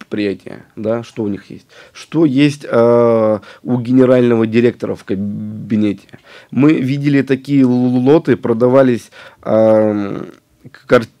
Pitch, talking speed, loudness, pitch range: 120 Hz, 105 wpm, -14 LUFS, 110-130 Hz